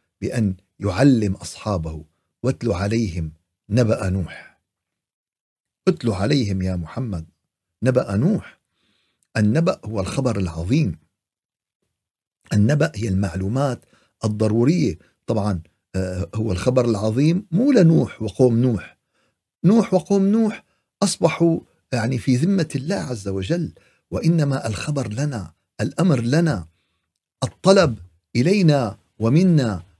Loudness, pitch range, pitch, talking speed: -21 LUFS, 95-145 Hz, 115 Hz, 95 wpm